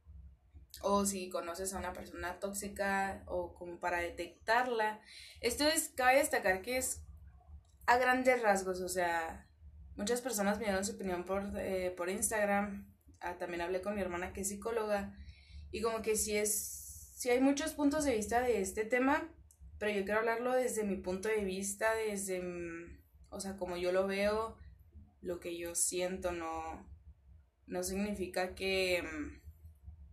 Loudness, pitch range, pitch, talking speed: -35 LUFS, 165-215 Hz, 190 Hz, 165 wpm